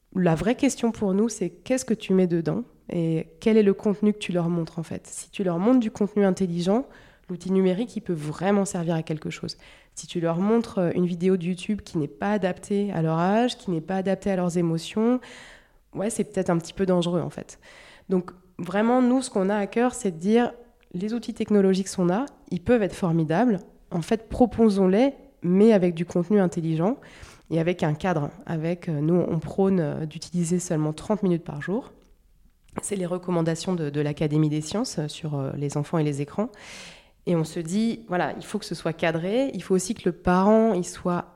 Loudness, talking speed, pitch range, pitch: -25 LUFS, 210 wpm, 170-210 Hz, 185 Hz